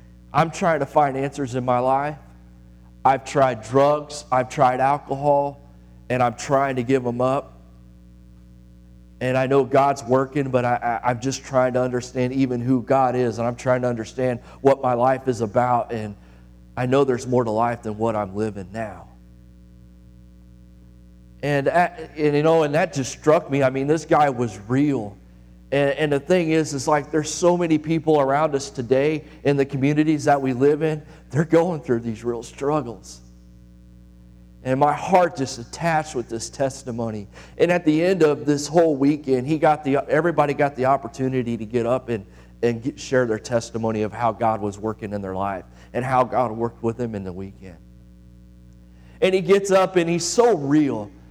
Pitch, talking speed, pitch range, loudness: 125 Hz, 185 wpm, 105-145 Hz, -21 LUFS